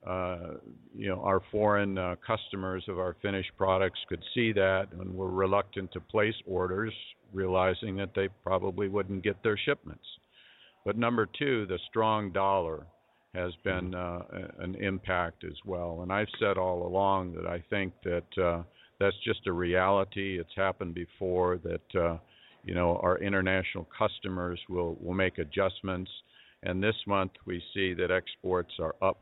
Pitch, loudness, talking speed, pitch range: 95 Hz, -31 LUFS, 160 wpm, 90-100 Hz